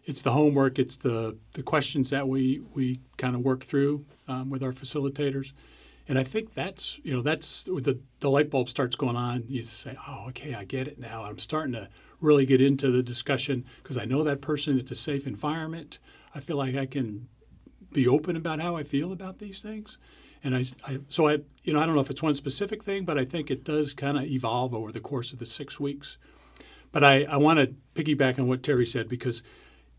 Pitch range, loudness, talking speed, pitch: 130-150 Hz, -28 LUFS, 225 wpm, 135 Hz